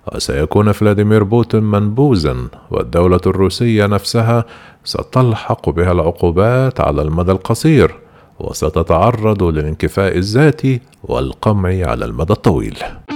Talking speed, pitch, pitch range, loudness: 90 wpm, 100 Hz, 85-115 Hz, -14 LUFS